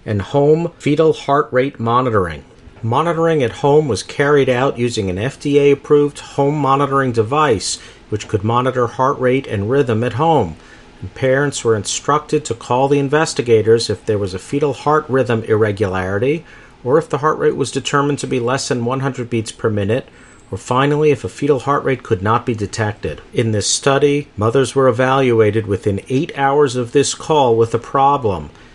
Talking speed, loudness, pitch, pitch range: 175 wpm, -16 LUFS, 130 Hz, 115-145 Hz